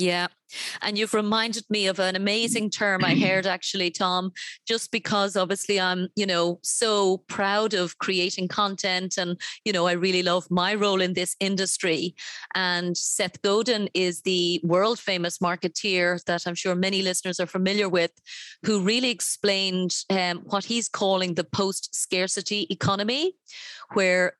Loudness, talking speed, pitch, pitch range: -24 LUFS, 155 wpm, 190 Hz, 180-205 Hz